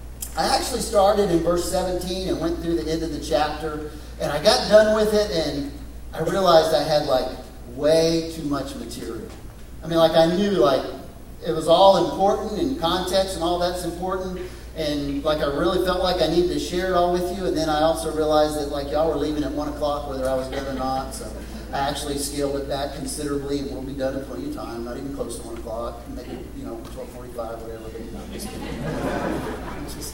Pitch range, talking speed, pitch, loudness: 140-175 Hz, 210 wpm, 155 Hz, -23 LUFS